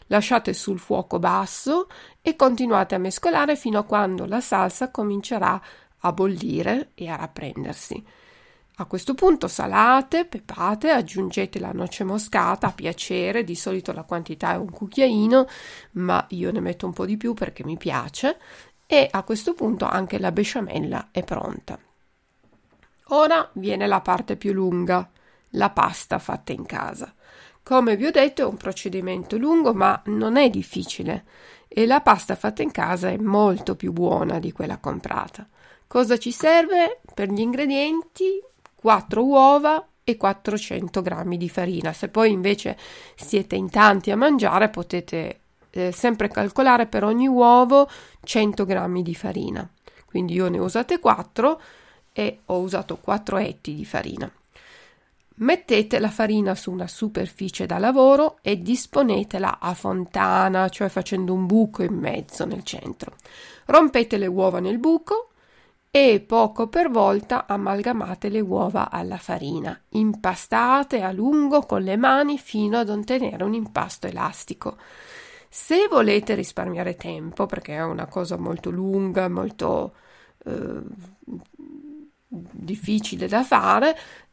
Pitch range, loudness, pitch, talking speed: 190-270 Hz, -22 LUFS, 215 Hz, 140 wpm